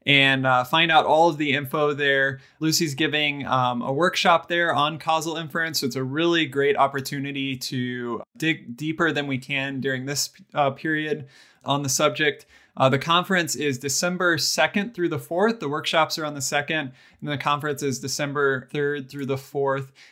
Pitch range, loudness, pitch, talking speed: 135-160 Hz, -23 LUFS, 145 Hz, 180 wpm